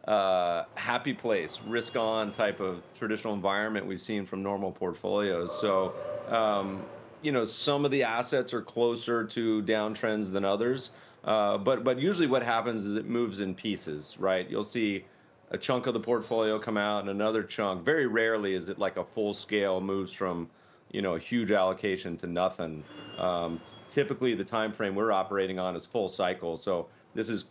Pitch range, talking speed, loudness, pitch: 95-115 Hz, 180 wpm, -30 LUFS, 105 Hz